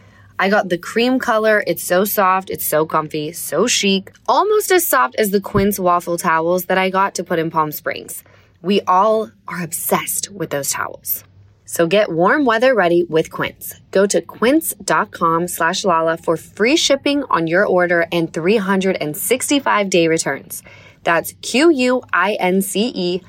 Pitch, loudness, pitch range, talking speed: 185 Hz, -17 LUFS, 165-215 Hz, 155 wpm